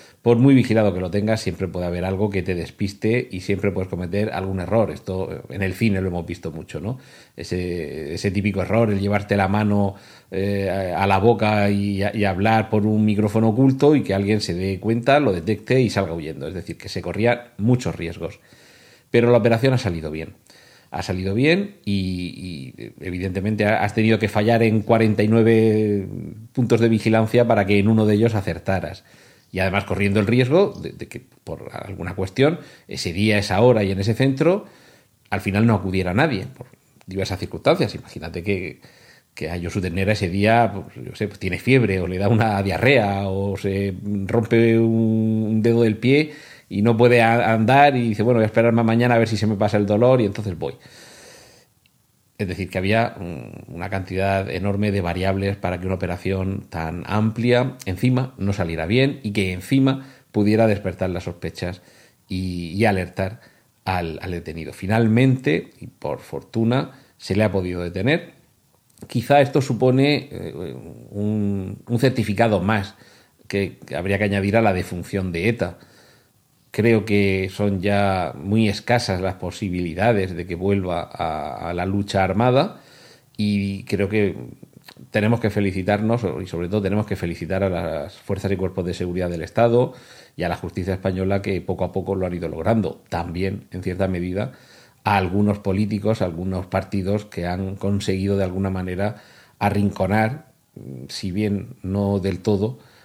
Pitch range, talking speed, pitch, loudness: 95-115 Hz, 170 wpm, 100 Hz, -21 LUFS